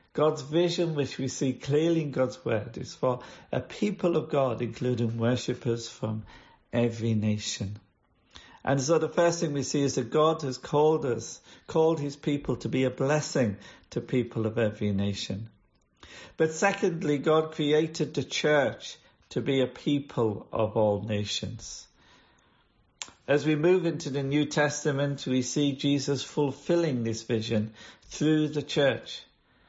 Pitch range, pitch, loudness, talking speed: 115-155 Hz, 135 Hz, -28 LUFS, 150 wpm